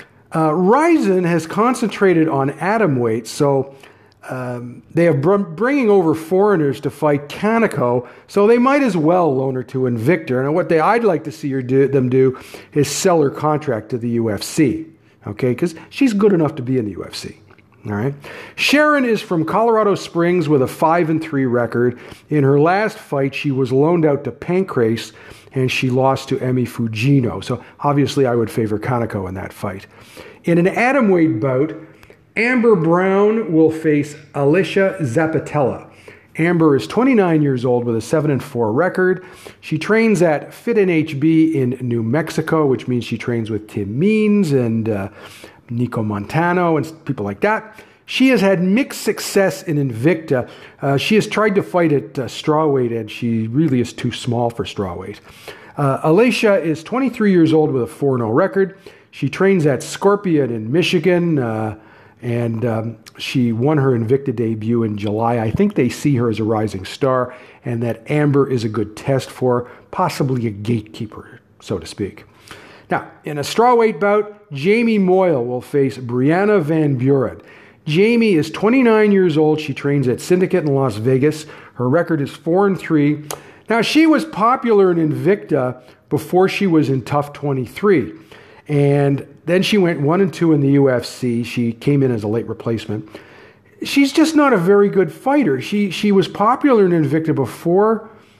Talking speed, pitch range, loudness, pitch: 175 wpm, 125-185 Hz, -17 LUFS, 145 Hz